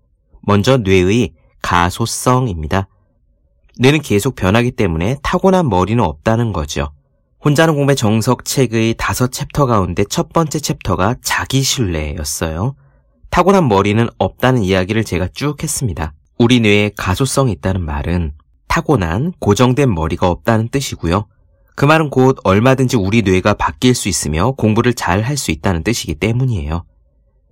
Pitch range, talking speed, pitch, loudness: 90-130 Hz, 315 characters per minute, 110 Hz, -15 LUFS